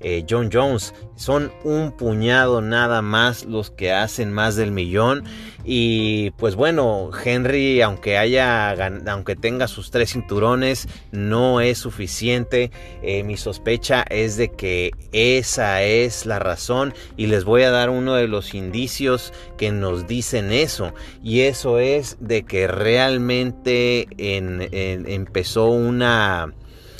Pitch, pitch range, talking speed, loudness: 115 Hz, 100-125 Hz, 135 wpm, -20 LUFS